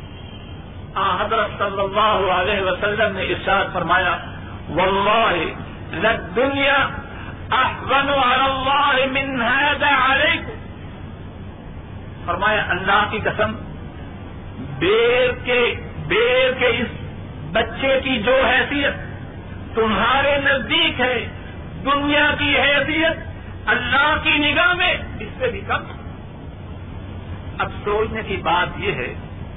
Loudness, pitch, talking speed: -18 LUFS, 255 Hz, 85 wpm